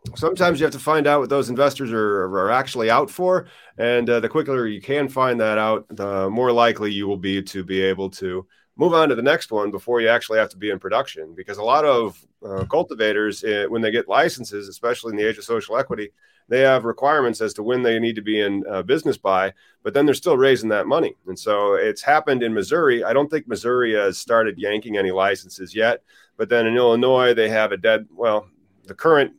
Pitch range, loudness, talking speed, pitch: 105-140 Hz, -20 LUFS, 230 wpm, 115 Hz